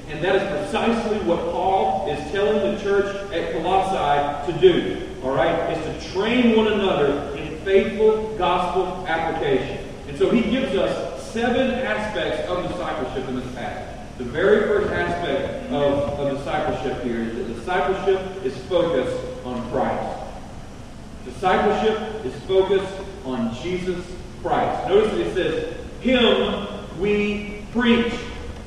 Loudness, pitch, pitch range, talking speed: -22 LUFS, 185 Hz, 150-205 Hz, 135 wpm